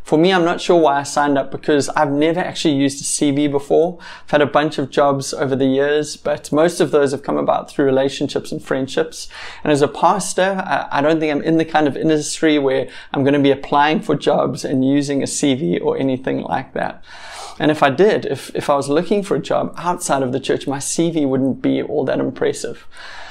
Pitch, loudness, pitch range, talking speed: 145 Hz, -17 LUFS, 140-155 Hz, 230 wpm